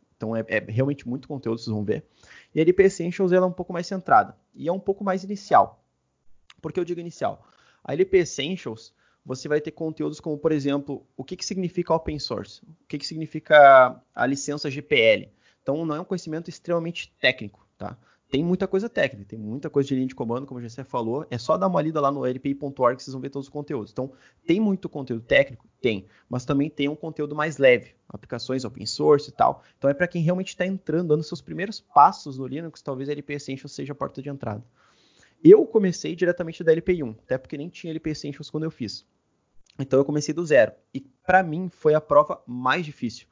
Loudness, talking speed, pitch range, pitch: -24 LUFS, 215 wpm, 130-175 Hz, 150 Hz